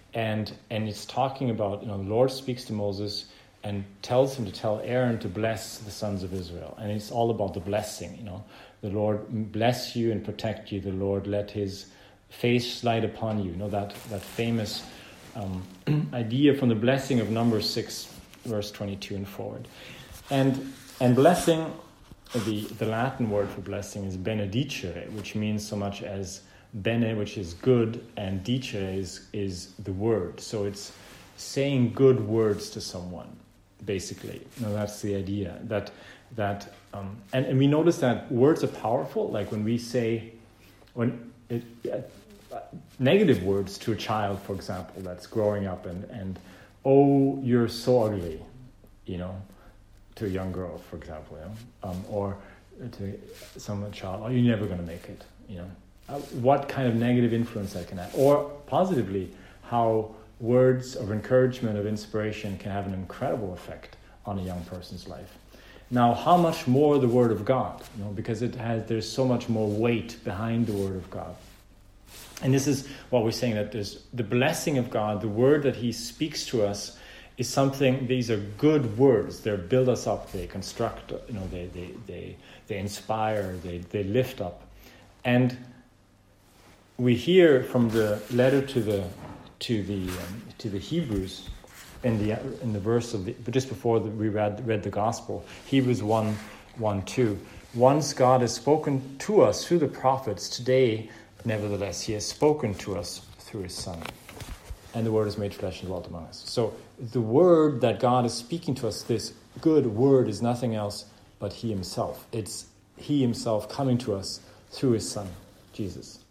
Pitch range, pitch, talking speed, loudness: 100-125 Hz, 110 Hz, 175 wpm, -27 LUFS